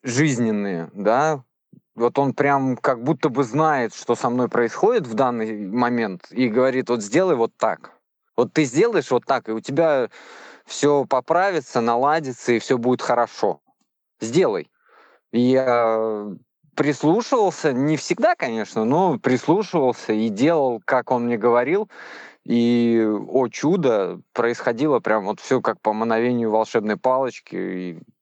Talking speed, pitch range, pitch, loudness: 140 wpm, 115-140 Hz, 125 Hz, -21 LUFS